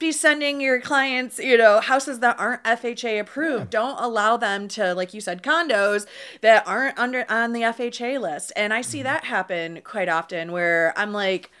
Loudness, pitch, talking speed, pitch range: -22 LUFS, 225 Hz, 185 wpm, 200-255 Hz